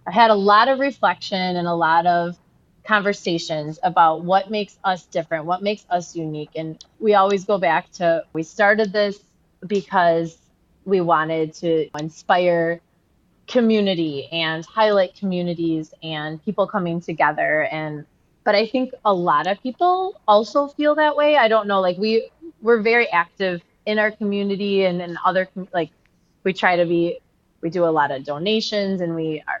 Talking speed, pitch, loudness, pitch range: 165 wpm, 185 Hz, -20 LUFS, 165-210 Hz